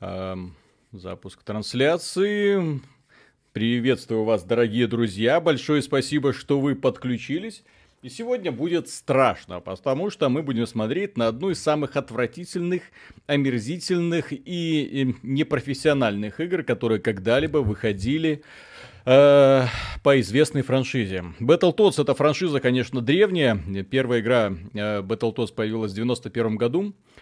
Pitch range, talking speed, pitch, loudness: 110-150 Hz, 110 wpm, 130 Hz, -23 LUFS